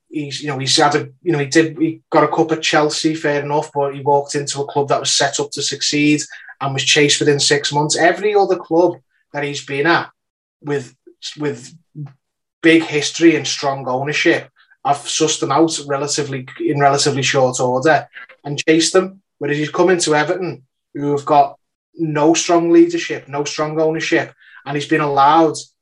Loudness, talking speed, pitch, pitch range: -16 LUFS, 190 wpm, 150 Hz, 140-160 Hz